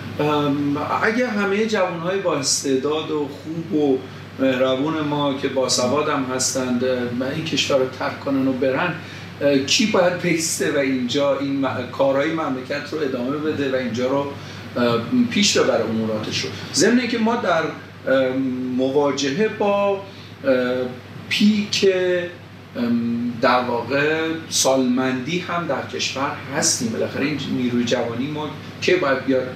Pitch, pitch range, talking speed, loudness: 140 Hz, 130-160 Hz, 130 wpm, -20 LUFS